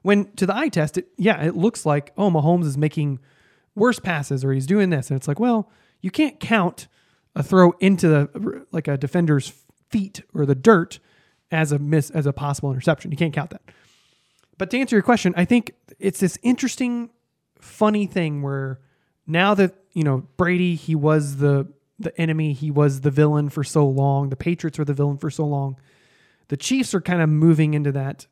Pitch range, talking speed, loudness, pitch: 145-190 Hz, 200 wpm, -21 LUFS, 160 Hz